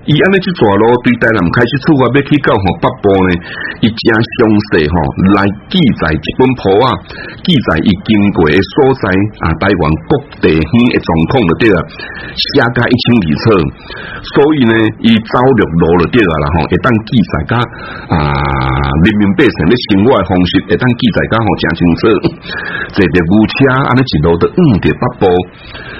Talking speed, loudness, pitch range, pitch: 250 characters per minute, -10 LUFS, 90-125 Hz, 105 Hz